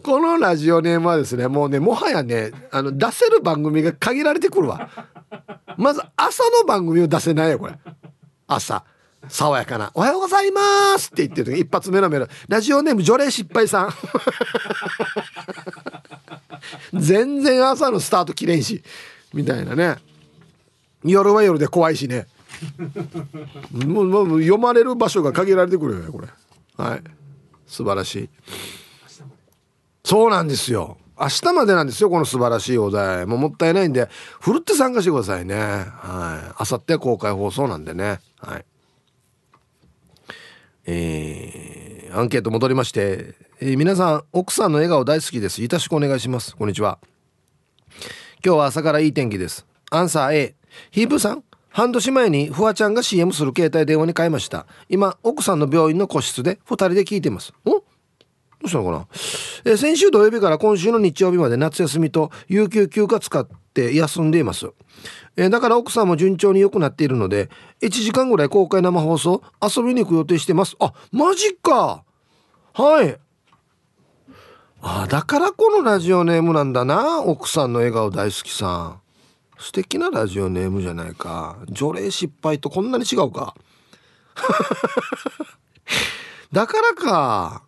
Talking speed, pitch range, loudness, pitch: 295 characters per minute, 135-215 Hz, -19 LUFS, 170 Hz